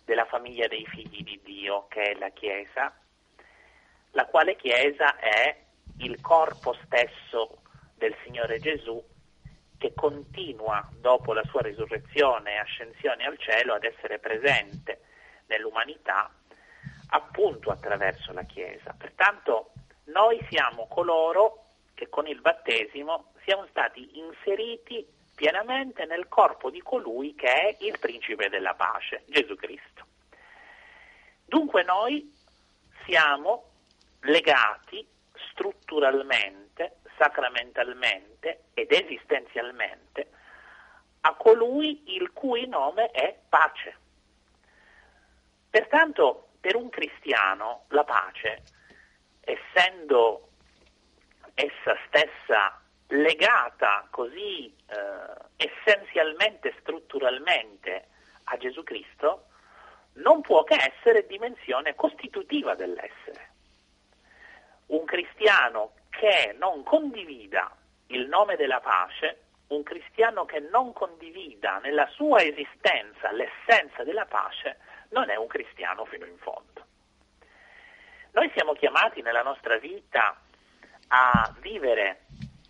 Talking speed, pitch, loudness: 100 wpm, 230 Hz, -25 LUFS